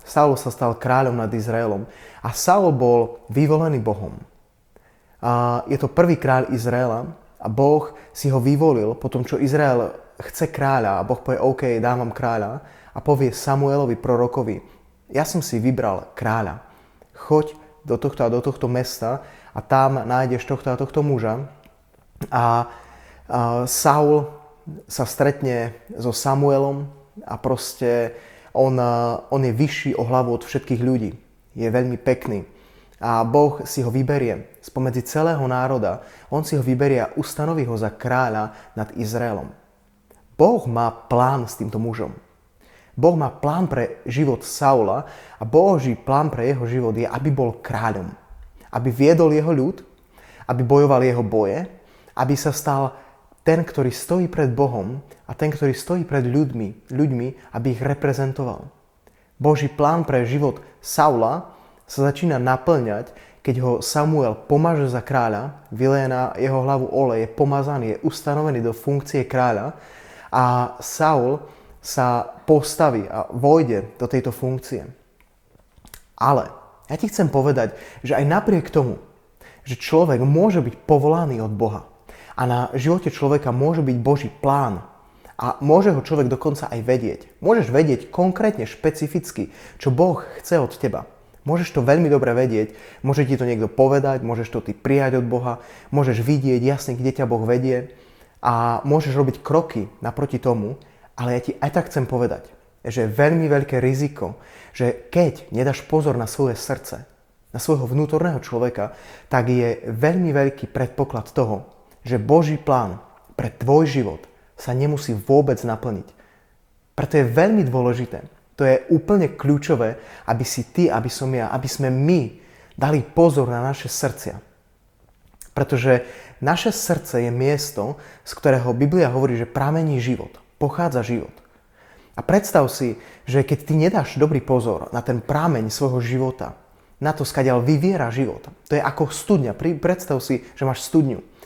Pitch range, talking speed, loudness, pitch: 120-145 Hz, 150 wpm, -20 LUFS, 130 Hz